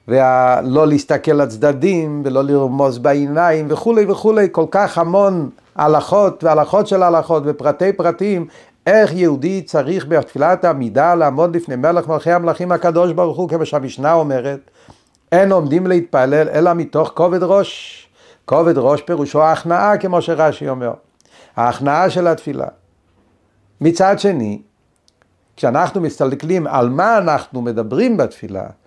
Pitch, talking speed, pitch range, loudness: 160 Hz, 130 wpm, 145-180 Hz, -15 LUFS